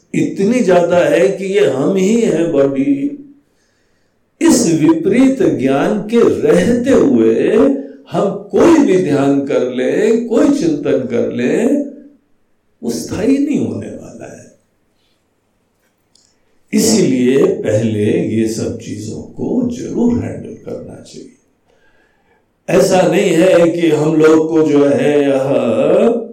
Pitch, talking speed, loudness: 190 Hz, 110 wpm, -13 LUFS